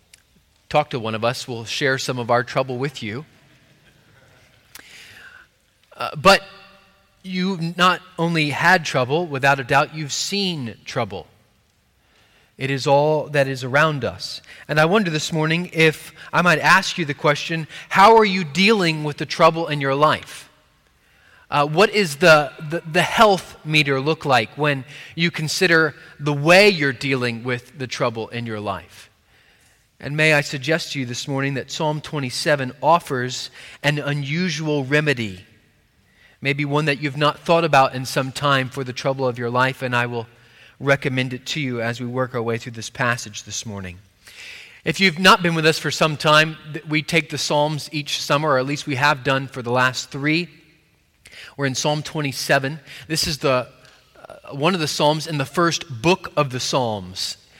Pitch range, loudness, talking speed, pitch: 130-160 Hz, -19 LUFS, 175 wpm, 145 Hz